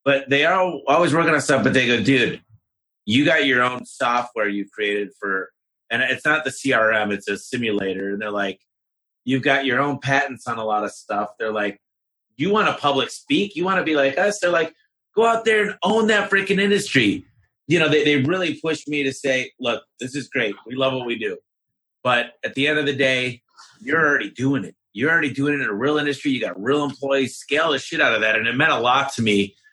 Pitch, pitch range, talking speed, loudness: 135 Hz, 120-160 Hz, 235 wpm, -20 LUFS